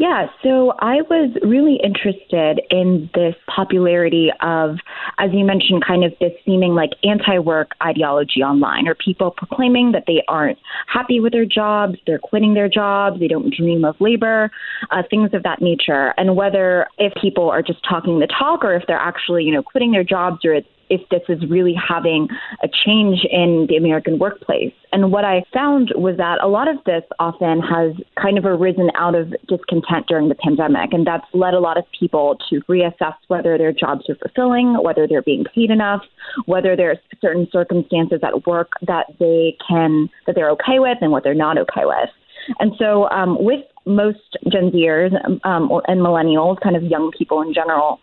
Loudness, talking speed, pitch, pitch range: -17 LUFS, 190 wpm, 180 Hz, 165-205 Hz